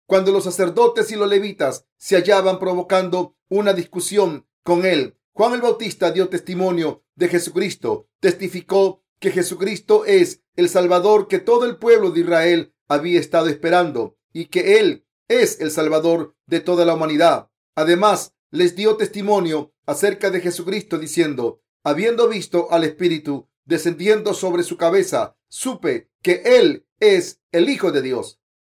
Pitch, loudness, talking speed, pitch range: 185 Hz, -18 LUFS, 145 wpm, 170-220 Hz